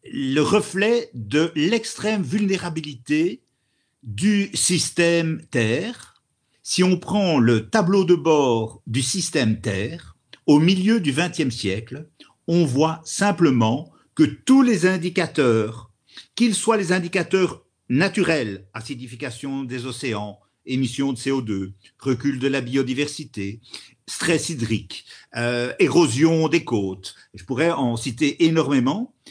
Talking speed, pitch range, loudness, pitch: 115 wpm, 125-175 Hz, -21 LUFS, 150 Hz